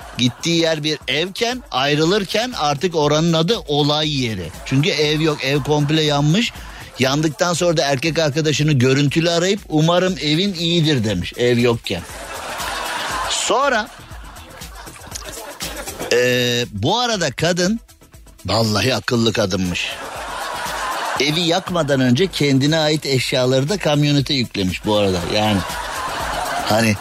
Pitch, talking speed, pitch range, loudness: 150 Hz, 110 wpm, 120-165 Hz, -18 LUFS